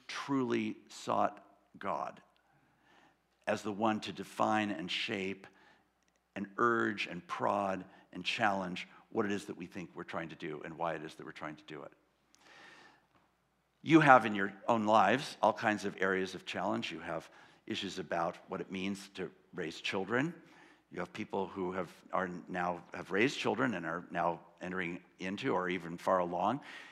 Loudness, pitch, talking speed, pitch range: -35 LUFS, 100 Hz, 170 wpm, 95-110 Hz